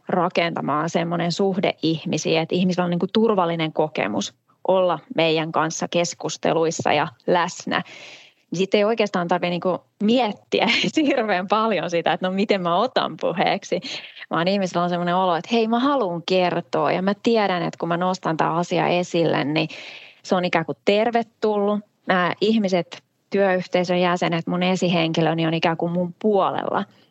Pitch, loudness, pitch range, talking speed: 180 Hz, -21 LUFS, 165-200 Hz, 155 wpm